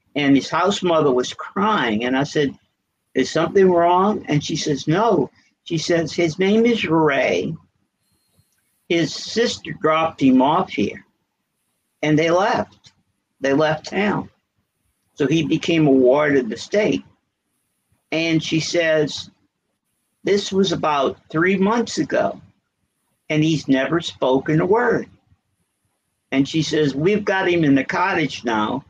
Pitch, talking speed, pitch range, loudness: 155 Hz, 140 wpm, 135-170 Hz, -19 LUFS